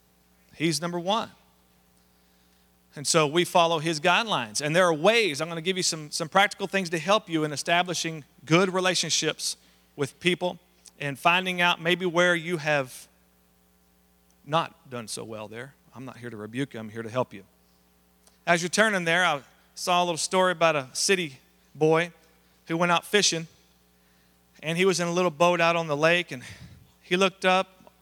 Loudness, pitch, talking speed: -25 LUFS, 160 Hz, 185 wpm